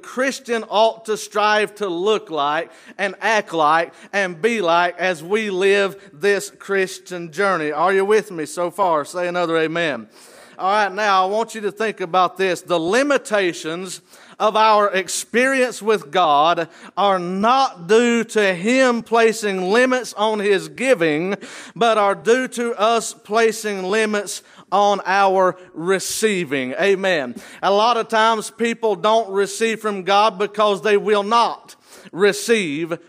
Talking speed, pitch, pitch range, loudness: 145 wpm, 205 Hz, 185-225 Hz, -18 LUFS